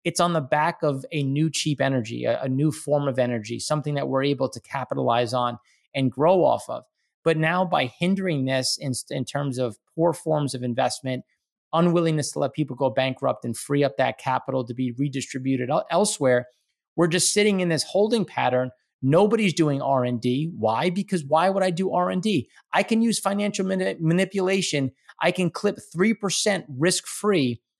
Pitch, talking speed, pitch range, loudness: 150 Hz, 175 wpm, 130-180 Hz, -24 LUFS